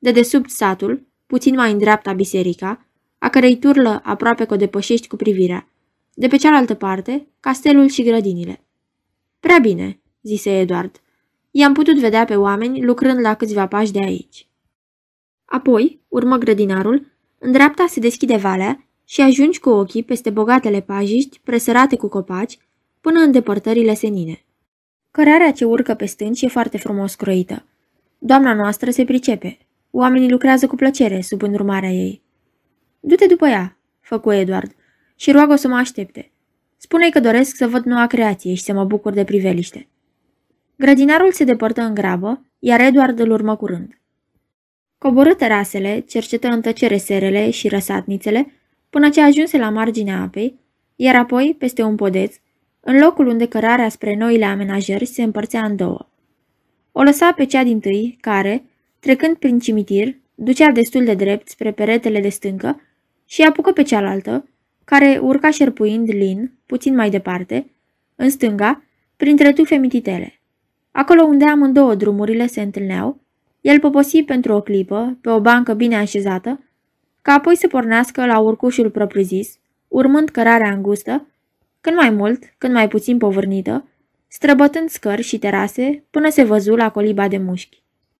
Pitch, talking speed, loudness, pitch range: 235 Hz, 150 wpm, -15 LUFS, 205-270 Hz